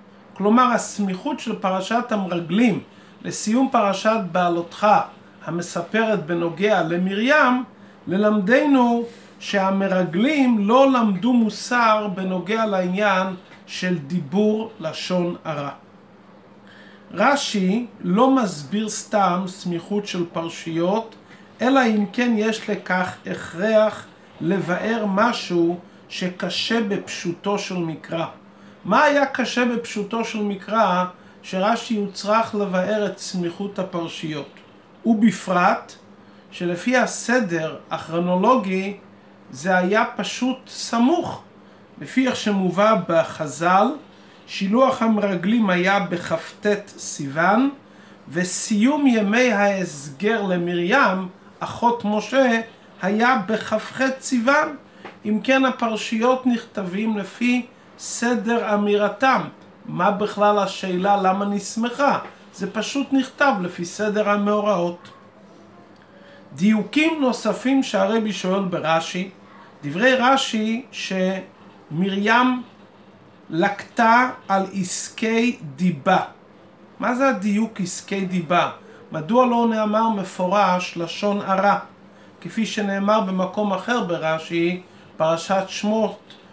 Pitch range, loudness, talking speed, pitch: 185-230 Hz, -21 LUFS, 90 wpm, 205 Hz